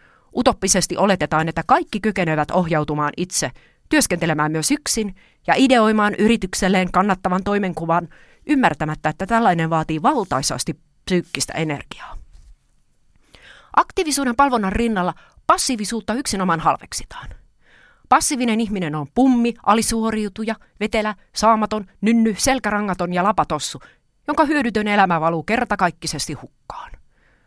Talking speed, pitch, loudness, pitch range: 100 wpm, 200 Hz, -19 LUFS, 165-230 Hz